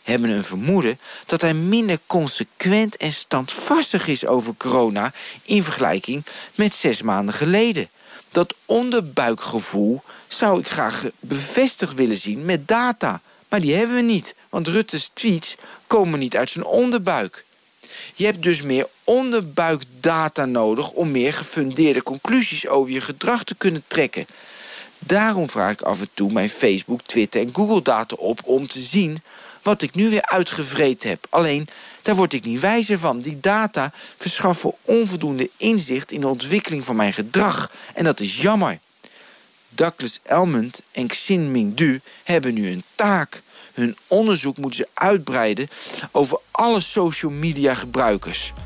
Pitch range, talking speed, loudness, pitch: 130-205 Hz, 145 wpm, -20 LUFS, 160 Hz